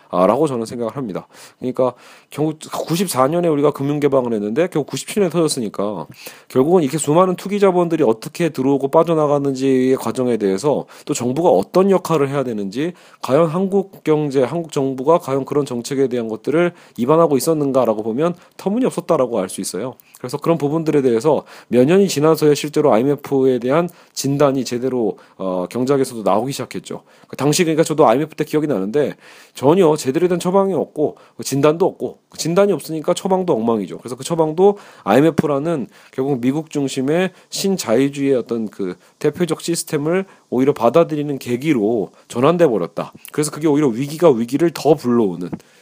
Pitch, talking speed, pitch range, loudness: 145 Hz, 395 characters per minute, 130-165 Hz, -18 LUFS